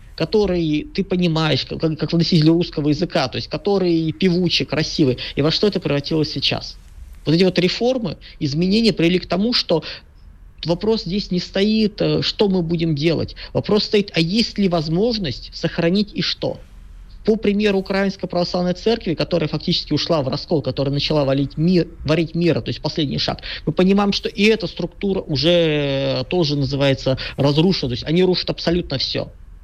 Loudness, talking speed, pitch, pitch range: -19 LUFS, 160 wpm, 165 Hz, 145-185 Hz